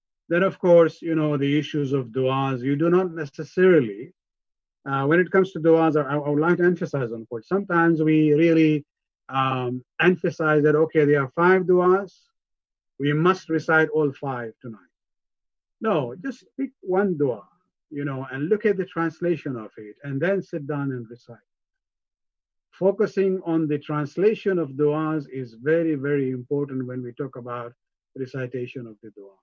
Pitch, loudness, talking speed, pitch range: 150 Hz, -22 LUFS, 165 wpm, 130-170 Hz